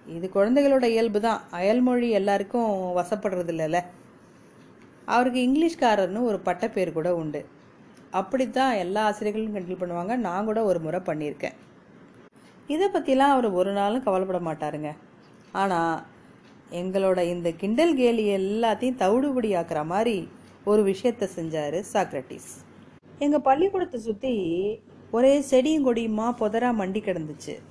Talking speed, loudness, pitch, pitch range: 115 wpm, -25 LUFS, 210 Hz, 180-245 Hz